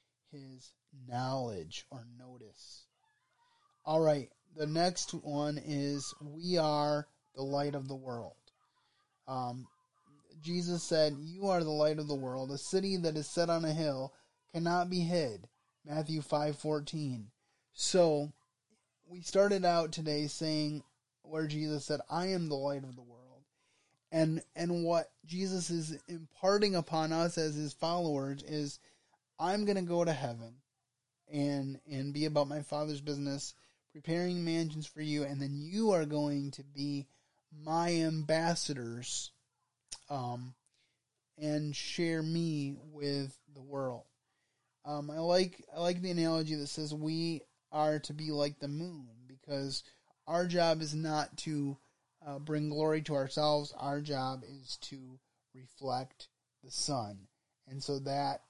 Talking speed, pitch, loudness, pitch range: 145 wpm, 150 Hz, -35 LUFS, 135-160 Hz